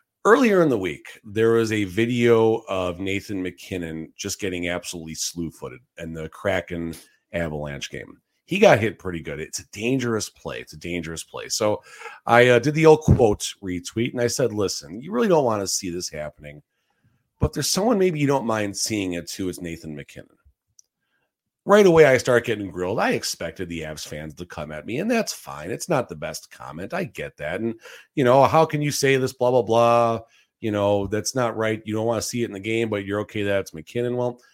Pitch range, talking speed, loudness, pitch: 85-120 Hz, 215 wpm, -22 LUFS, 105 Hz